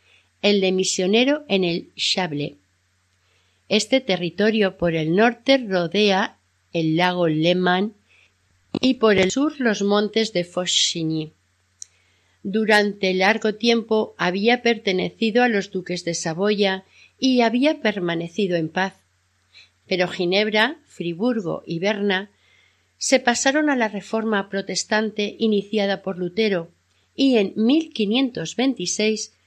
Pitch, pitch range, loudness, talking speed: 195 Hz, 170-220 Hz, -21 LUFS, 110 wpm